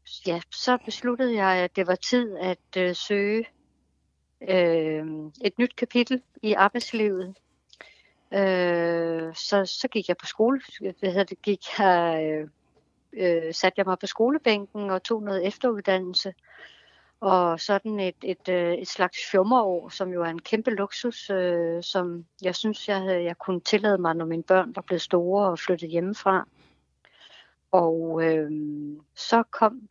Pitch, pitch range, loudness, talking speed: 190 Hz, 175-210 Hz, -25 LUFS, 140 wpm